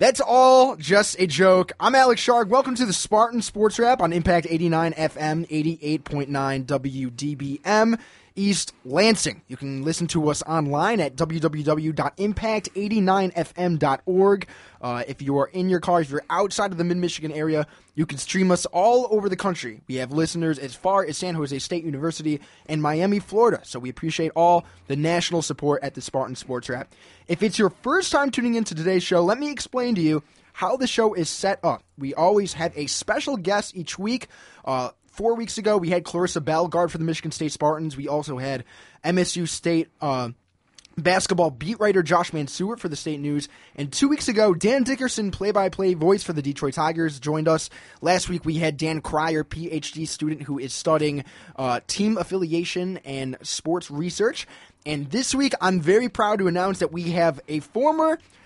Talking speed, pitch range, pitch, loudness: 185 wpm, 150-195 Hz, 170 Hz, -23 LUFS